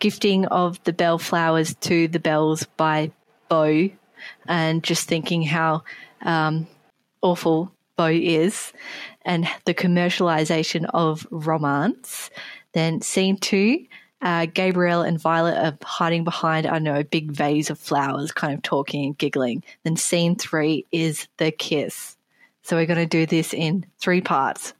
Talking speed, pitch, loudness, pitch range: 145 wpm, 165 Hz, -22 LUFS, 160-175 Hz